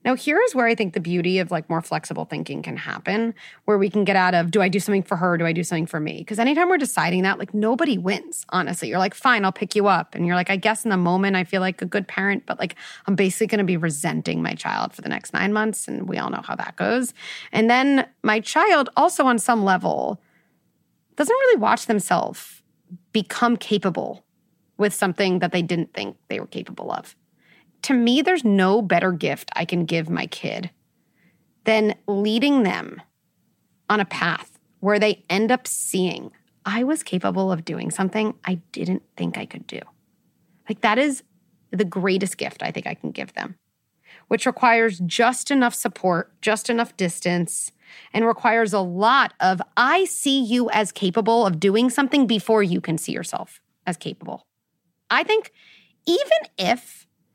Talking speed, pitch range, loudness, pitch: 195 wpm, 185-235 Hz, -21 LUFS, 205 Hz